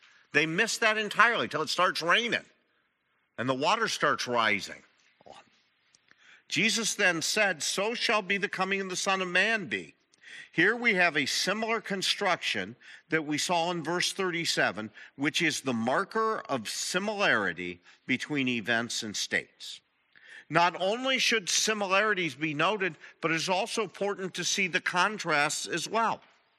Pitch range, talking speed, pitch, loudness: 160-210 Hz, 150 wpm, 185 Hz, -27 LUFS